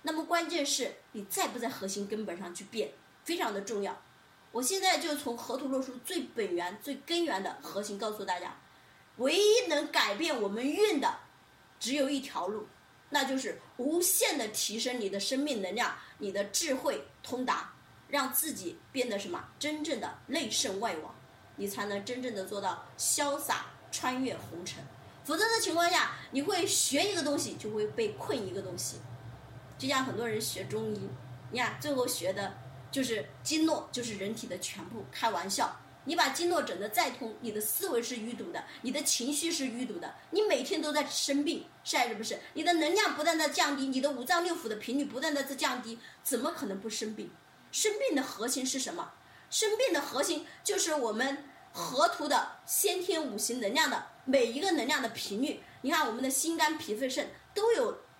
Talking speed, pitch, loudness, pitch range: 275 characters per minute, 275 Hz, -32 LUFS, 230-325 Hz